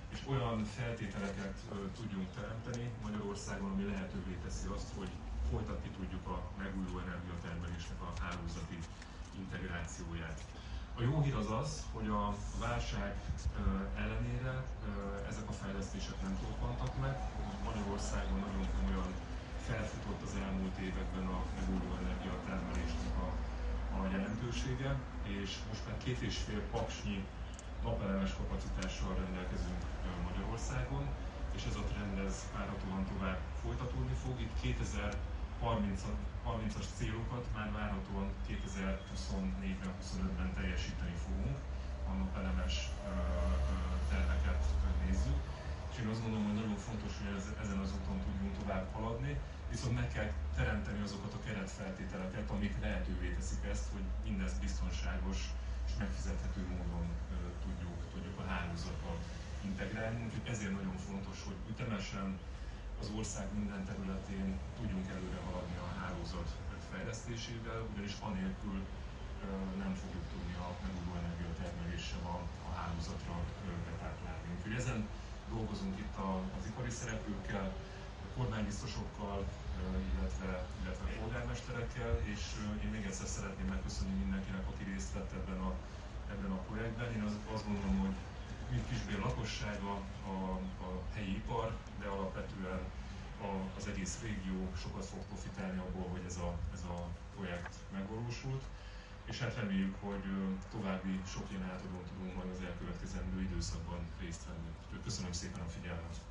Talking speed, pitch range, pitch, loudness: 120 wpm, 85-100 Hz, 95 Hz, -41 LUFS